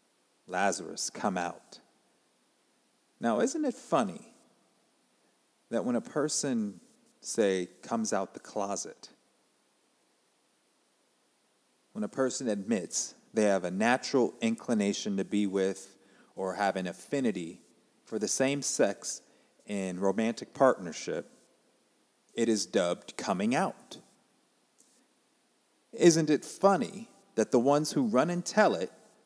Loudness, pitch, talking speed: -30 LUFS, 120 Hz, 115 wpm